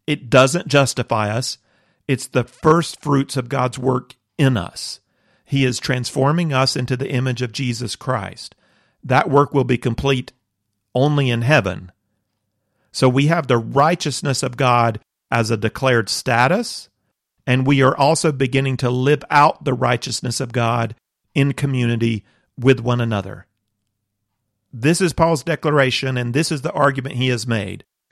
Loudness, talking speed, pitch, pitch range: -18 LUFS, 150 wpm, 130 Hz, 115-140 Hz